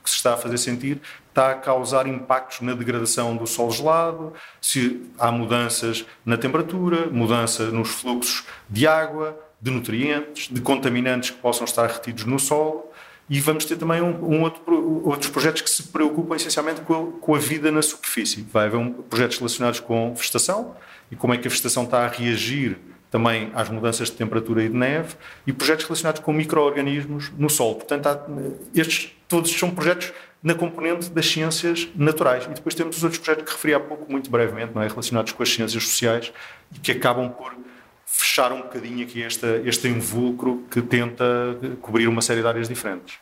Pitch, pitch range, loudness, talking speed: 130 Hz, 120-155 Hz, -22 LUFS, 185 wpm